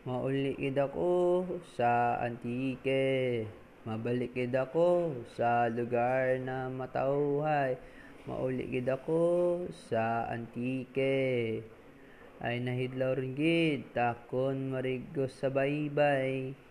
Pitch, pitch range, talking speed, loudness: 130 Hz, 120-140 Hz, 80 wpm, -32 LUFS